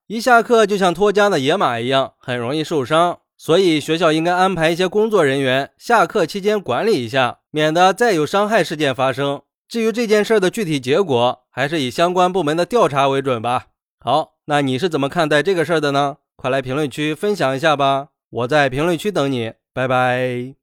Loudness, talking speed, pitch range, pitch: -17 LUFS, 305 characters per minute, 135-185 Hz, 155 Hz